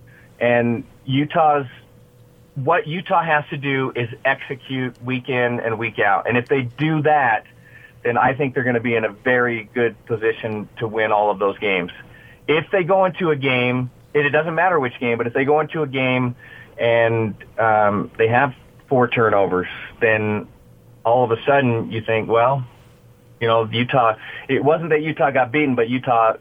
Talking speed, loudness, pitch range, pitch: 185 wpm, -19 LUFS, 115-140 Hz, 125 Hz